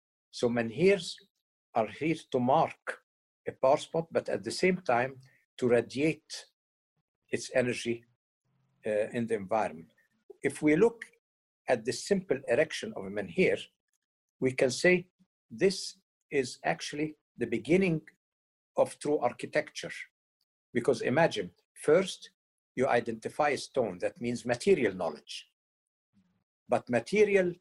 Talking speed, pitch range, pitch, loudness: 120 wpm, 120-185 Hz, 145 Hz, -30 LUFS